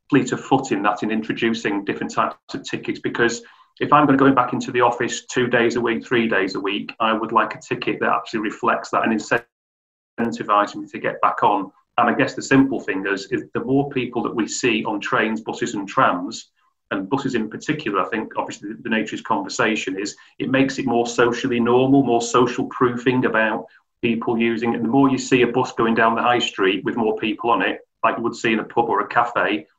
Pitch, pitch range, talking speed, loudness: 120 Hz, 115-130 Hz, 230 wpm, -20 LUFS